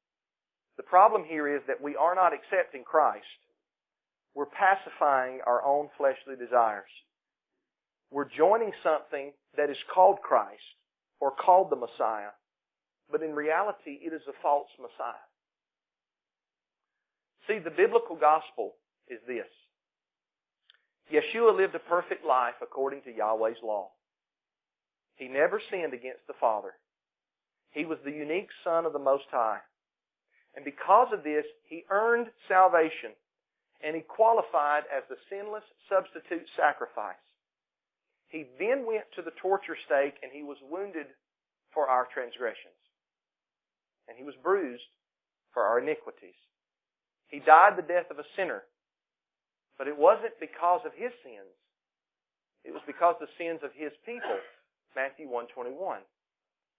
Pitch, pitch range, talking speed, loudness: 160 Hz, 140-210 Hz, 135 wpm, -28 LUFS